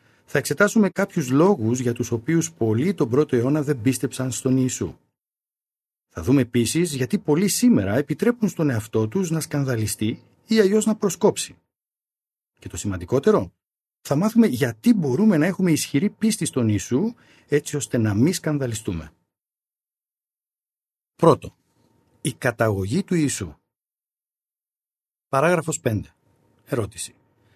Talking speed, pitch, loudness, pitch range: 125 wpm, 145 Hz, -22 LUFS, 120-185 Hz